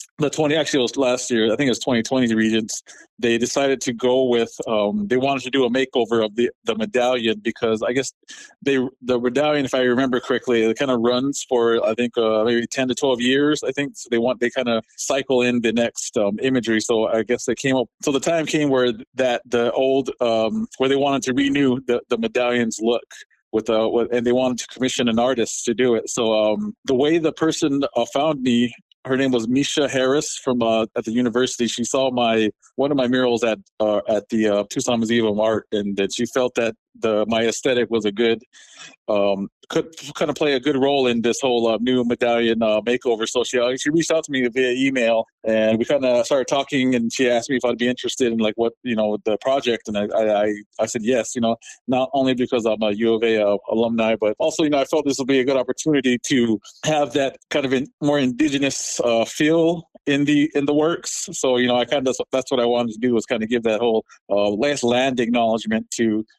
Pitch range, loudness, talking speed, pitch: 115-135 Hz, -20 LUFS, 235 wpm, 125 Hz